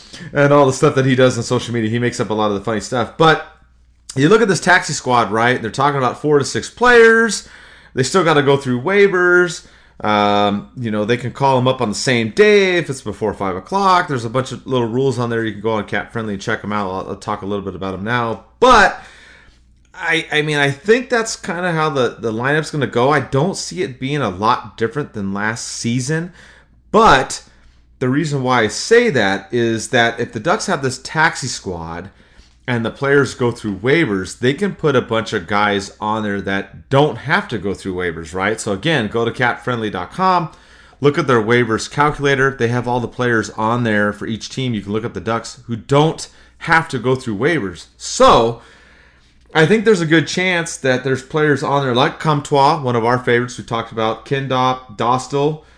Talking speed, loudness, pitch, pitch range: 225 wpm, -16 LUFS, 120 Hz, 105-145 Hz